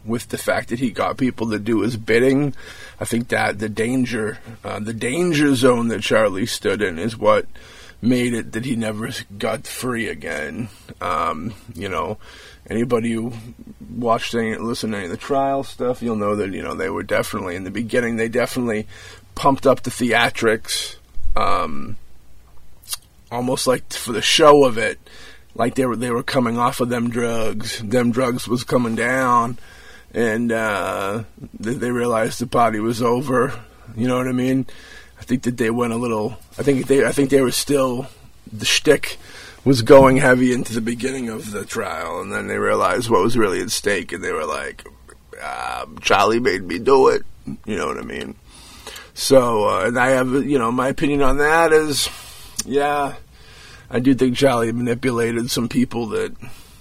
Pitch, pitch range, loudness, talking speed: 120 Hz, 115-130 Hz, -19 LUFS, 180 wpm